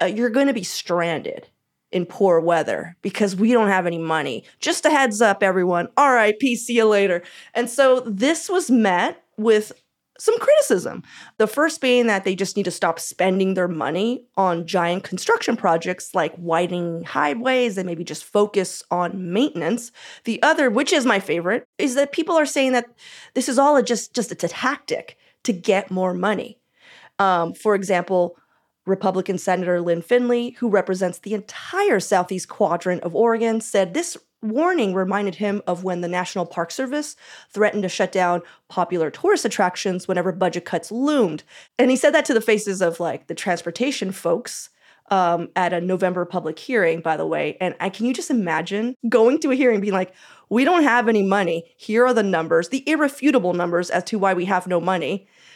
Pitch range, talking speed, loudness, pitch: 180-245 Hz, 185 wpm, -21 LUFS, 200 Hz